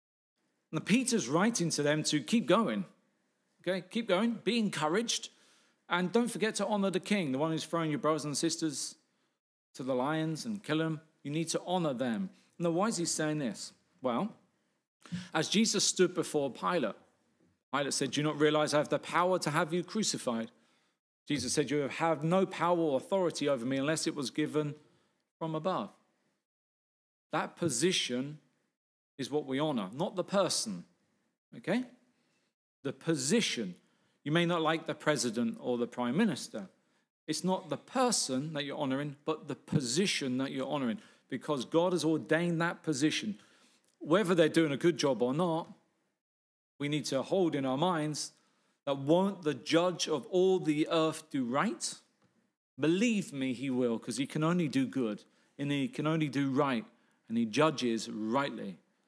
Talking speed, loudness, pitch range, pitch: 170 wpm, -32 LUFS, 145-185 Hz, 160 Hz